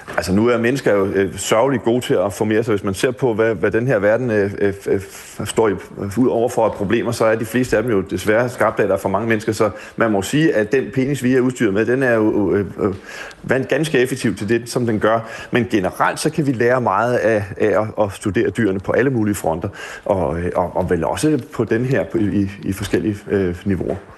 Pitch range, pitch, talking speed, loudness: 100-125 Hz, 110 Hz, 240 wpm, -18 LUFS